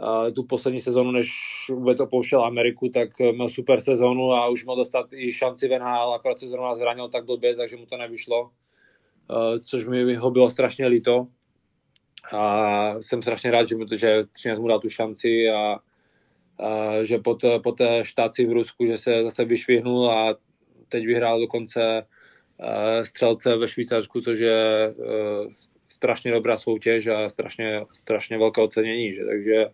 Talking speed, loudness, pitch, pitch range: 155 wpm, -23 LUFS, 115 Hz, 110-125 Hz